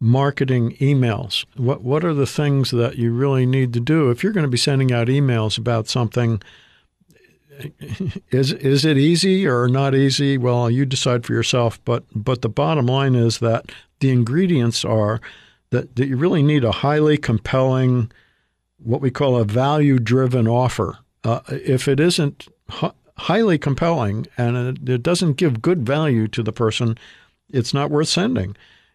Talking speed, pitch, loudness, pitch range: 160 wpm, 130 Hz, -19 LUFS, 120-145 Hz